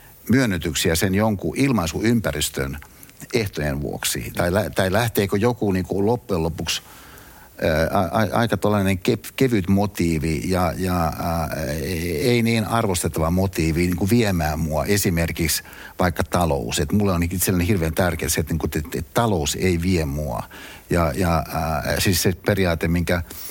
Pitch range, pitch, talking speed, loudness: 80-100 Hz, 90 Hz, 145 wpm, -21 LUFS